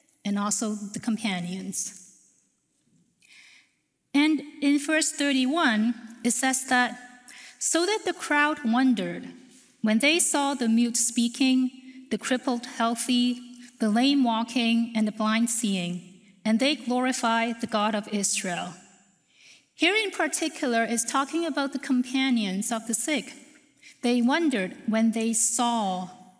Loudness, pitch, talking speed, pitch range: -25 LUFS, 245 Hz, 125 wpm, 220-275 Hz